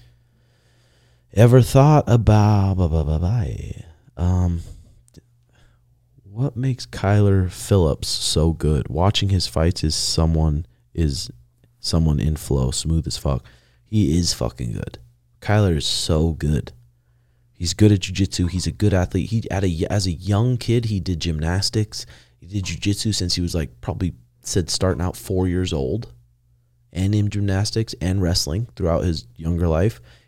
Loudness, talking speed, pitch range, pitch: -21 LUFS, 145 wpm, 80-110 Hz, 95 Hz